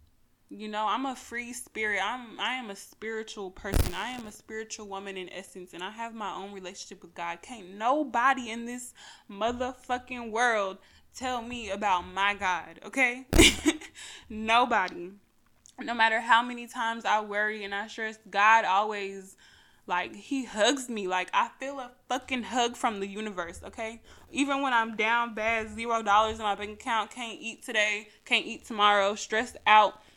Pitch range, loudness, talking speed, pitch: 200-245 Hz, -28 LUFS, 170 wpm, 220 Hz